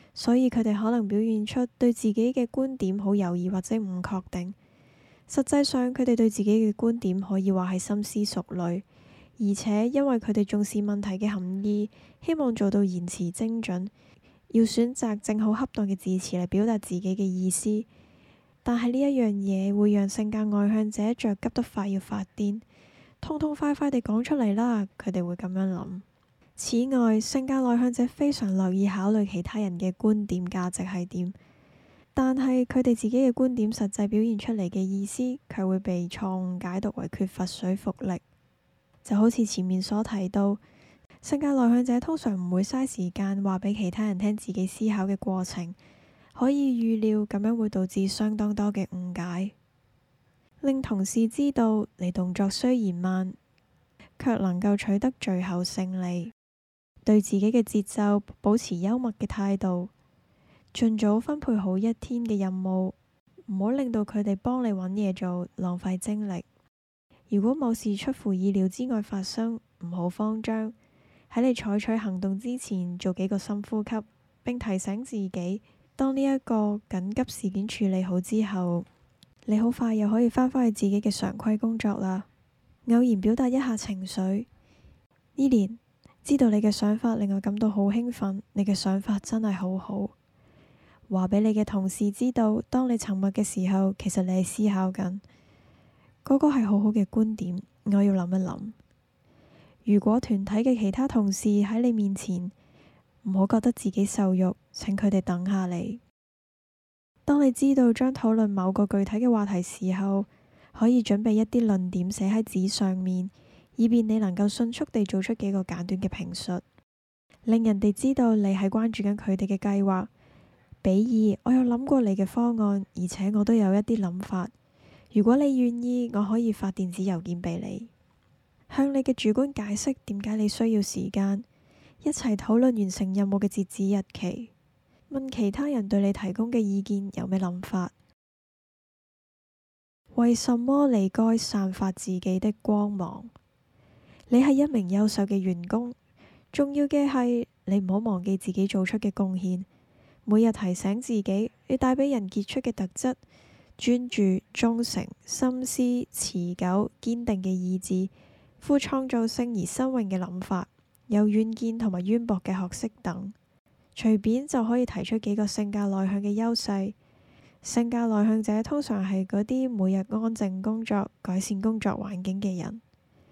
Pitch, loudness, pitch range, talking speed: 210 Hz, -27 LUFS, 190-230 Hz, 240 characters per minute